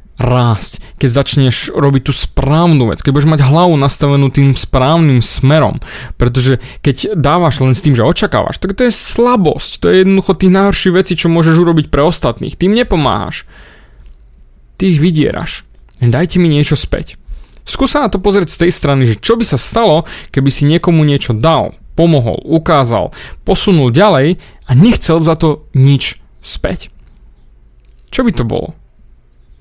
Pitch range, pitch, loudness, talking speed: 130-175 Hz, 145 Hz, -11 LUFS, 160 wpm